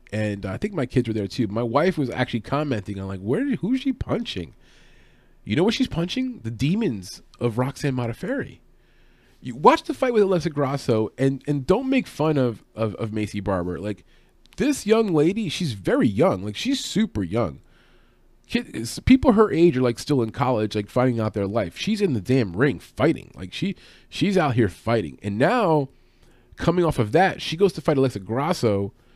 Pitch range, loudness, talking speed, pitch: 110-185 Hz, -23 LUFS, 195 wpm, 135 Hz